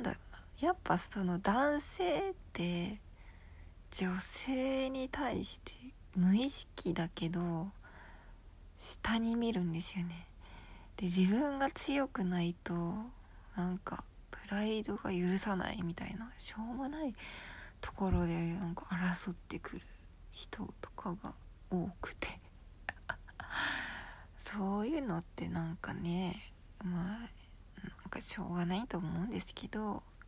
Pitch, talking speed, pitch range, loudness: 185 Hz, 220 characters per minute, 170-220 Hz, -38 LUFS